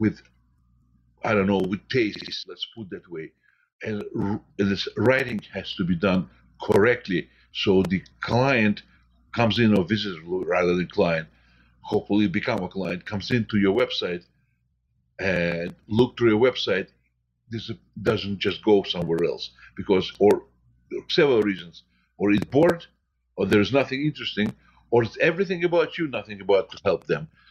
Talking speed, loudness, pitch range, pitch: 155 wpm, -24 LUFS, 85-115 Hz, 100 Hz